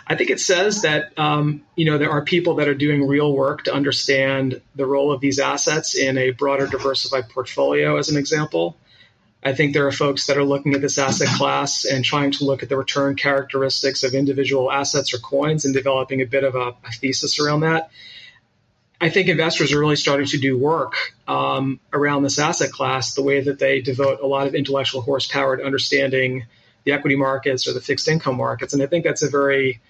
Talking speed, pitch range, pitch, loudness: 215 wpm, 135-145 Hz, 140 Hz, -19 LUFS